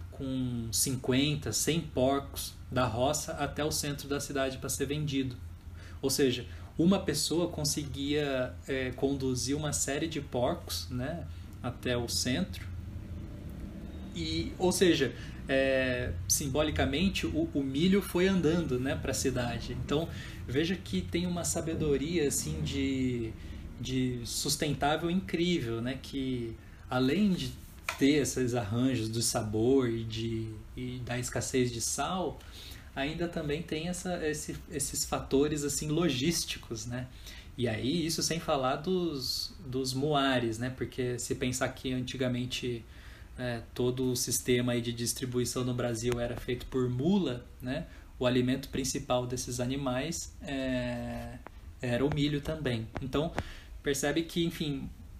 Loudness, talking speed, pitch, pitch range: -32 LUFS, 130 wpm, 125 Hz, 115-145 Hz